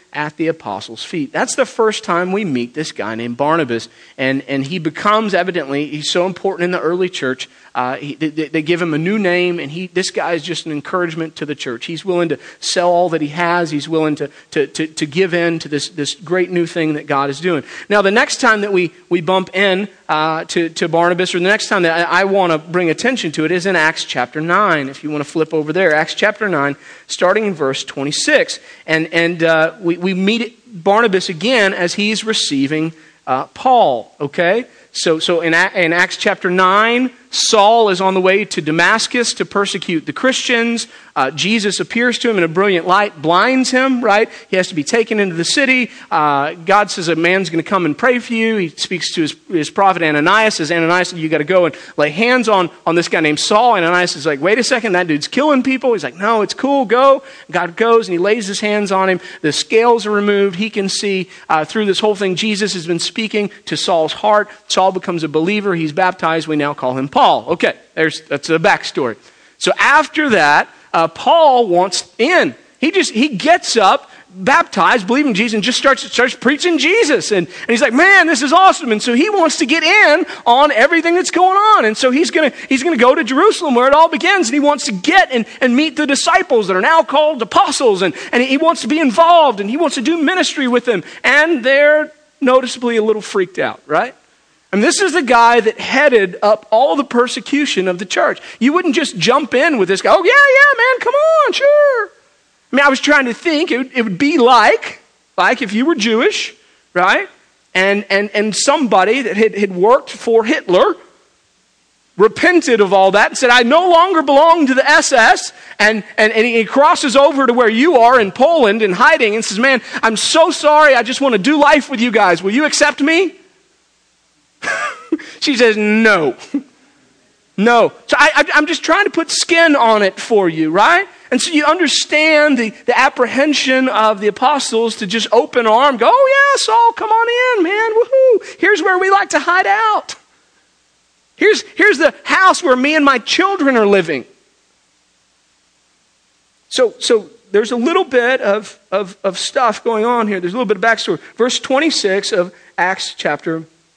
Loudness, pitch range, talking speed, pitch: -13 LUFS, 180-285 Hz, 210 wpm, 220 Hz